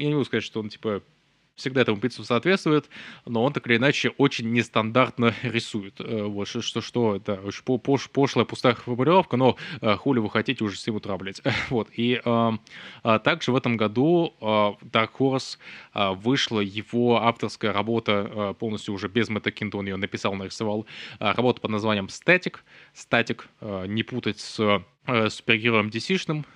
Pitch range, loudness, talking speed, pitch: 105-125 Hz, -24 LUFS, 165 wpm, 115 Hz